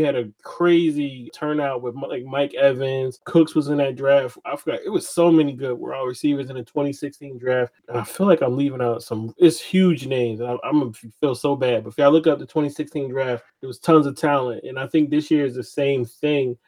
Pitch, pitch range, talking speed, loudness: 140 Hz, 125-150 Hz, 235 wpm, -21 LUFS